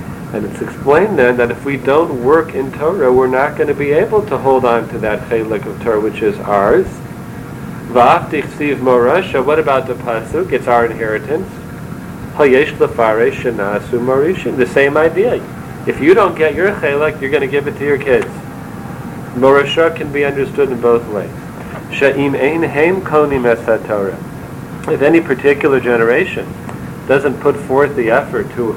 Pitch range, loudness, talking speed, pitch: 120-145 Hz, -14 LUFS, 160 wpm, 135 Hz